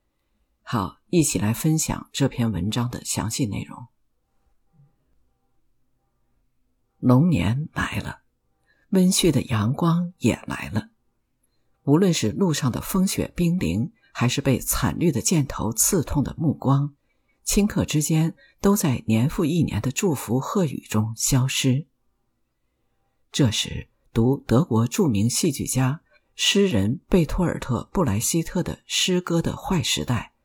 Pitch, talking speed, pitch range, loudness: 135 Hz, 185 characters per minute, 115-170 Hz, -23 LUFS